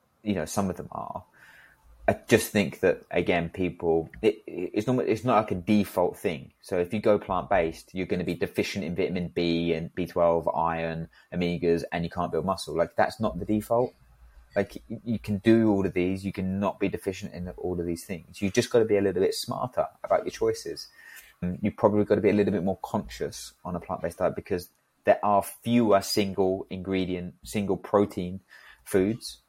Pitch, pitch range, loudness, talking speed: 95 Hz, 85-105 Hz, -27 LUFS, 210 wpm